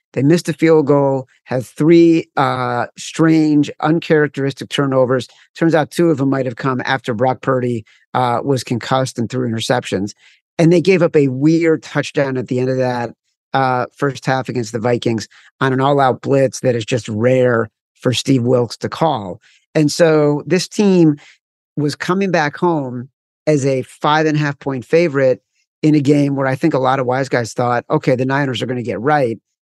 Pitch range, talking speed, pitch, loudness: 125-155 Hz, 195 wpm, 135 Hz, -16 LUFS